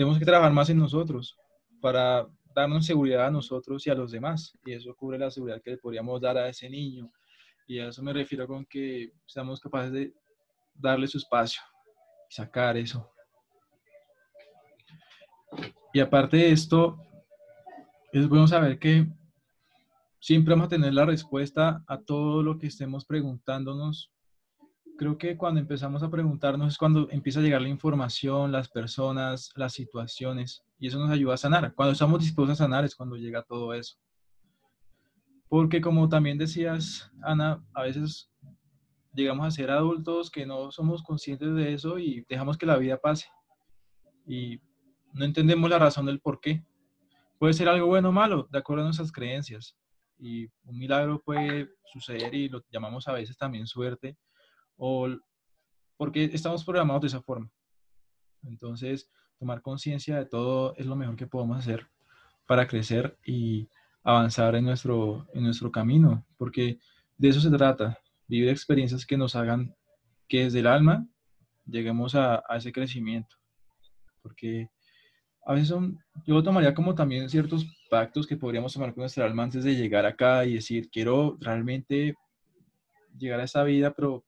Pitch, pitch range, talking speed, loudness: 140 Hz, 125-155 Hz, 160 wpm, -27 LUFS